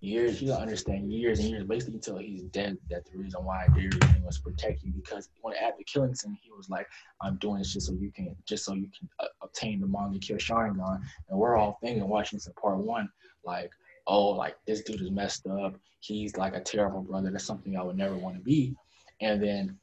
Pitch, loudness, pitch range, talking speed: 100 Hz, -31 LUFS, 95-110 Hz, 235 wpm